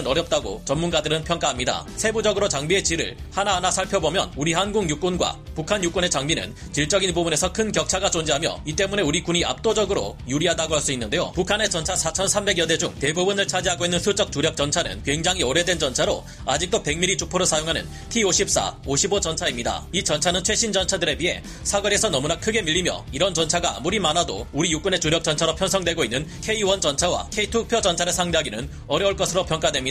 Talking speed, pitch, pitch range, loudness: 430 characters per minute, 180 Hz, 160-195 Hz, -22 LUFS